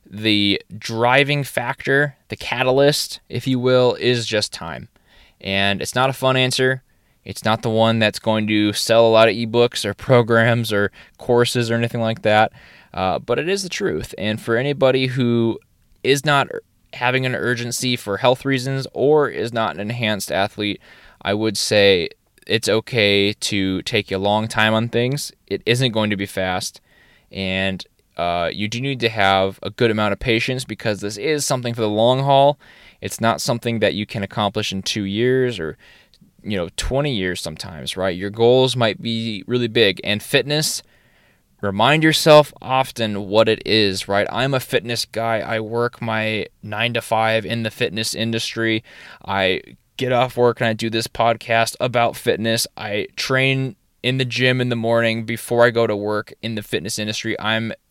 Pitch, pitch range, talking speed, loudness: 115 Hz, 105-125 Hz, 180 wpm, -19 LUFS